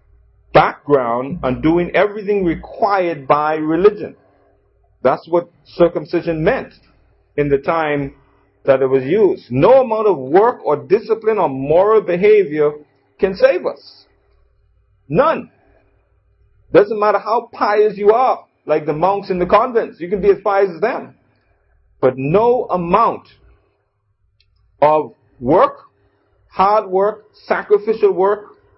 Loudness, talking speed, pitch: -16 LUFS, 125 wpm, 165 Hz